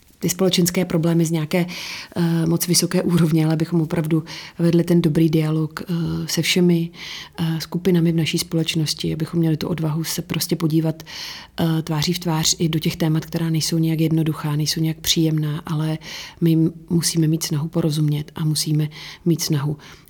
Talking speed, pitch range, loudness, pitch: 165 wpm, 160-170 Hz, -20 LUFS, 165 Hz